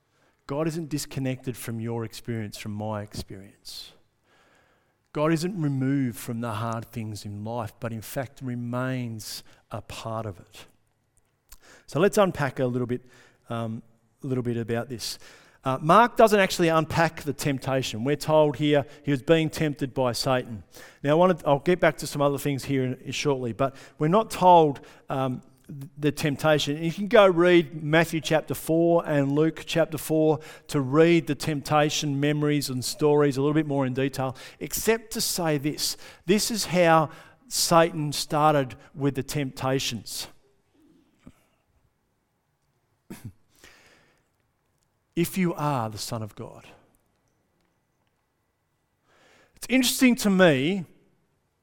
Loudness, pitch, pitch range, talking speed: -25 LUFS, 145 Hz, 125-160 Hz, 145 wpm